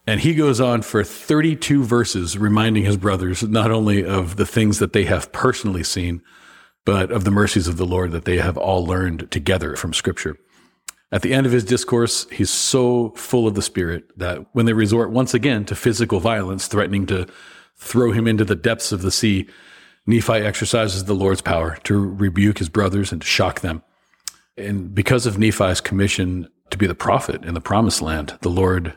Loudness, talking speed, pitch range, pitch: -19 LUFS, 195 wpm, 95-115 Hz, 105 Hz